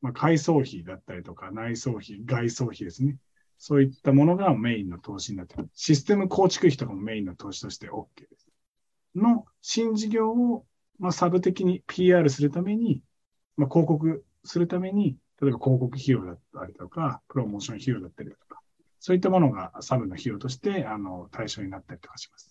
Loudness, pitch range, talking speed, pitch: -26 LUFS, 115-180 Hz, 375 characters per minute, 140 Hz